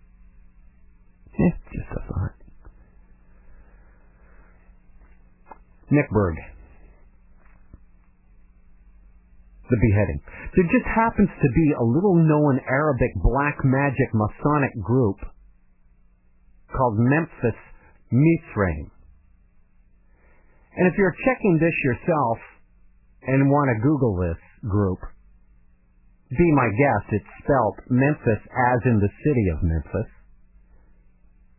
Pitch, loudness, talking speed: 105 Hz, -22 LUFS, 85 wpm